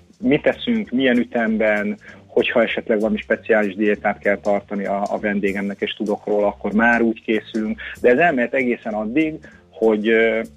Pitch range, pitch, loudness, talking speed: 105-120 Hz, 110 Hz, -19 LUFS, 155 wpm